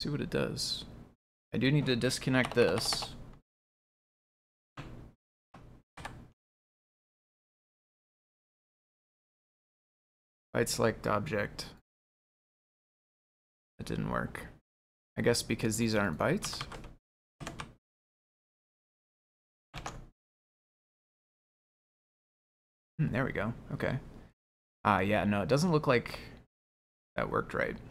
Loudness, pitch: -32 LUFS, 105 Hz